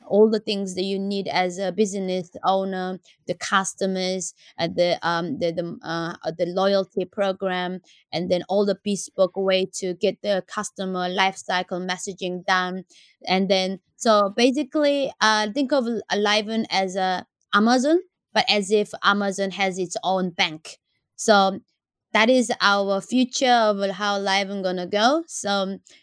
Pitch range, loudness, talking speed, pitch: 185-210 Hz, -23 LUFS, 150 wpm, 195 Hz